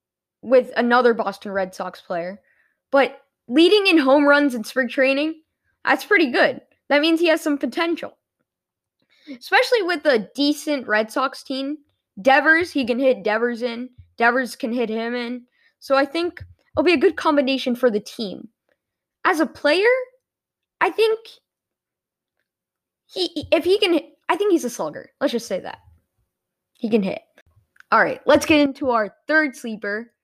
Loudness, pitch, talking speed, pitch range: -20 LUFS, 275 Hz, 160 wpm, 240-320 Hz